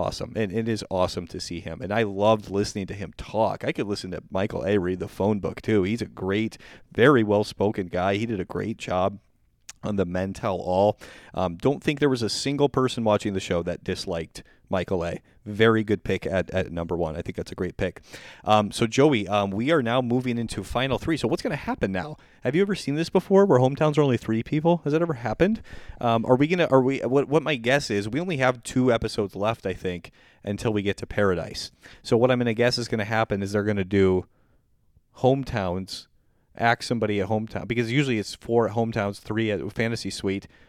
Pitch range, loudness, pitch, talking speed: 95-120 Hz, -25 LUFS, 110 Hz, 225 wpm